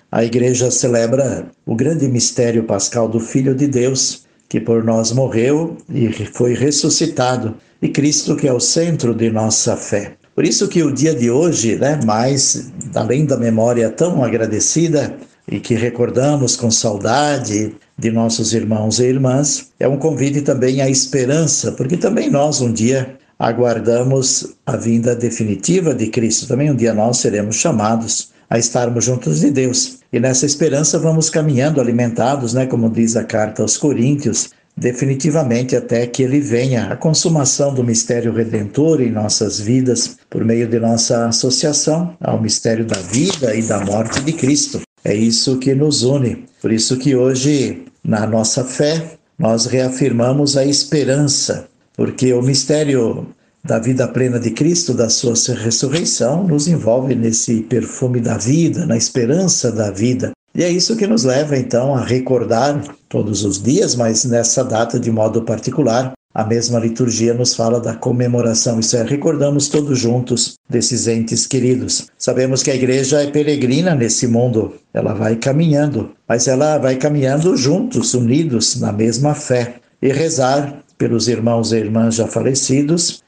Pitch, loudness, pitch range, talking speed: 125 Hz, -15 LUFS, 115-145 Hz, 155 wpm